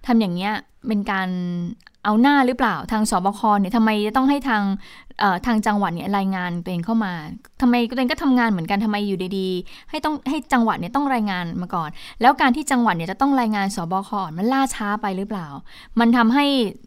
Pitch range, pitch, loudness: 190-250 Hz, 210 Hz, -21 LUFS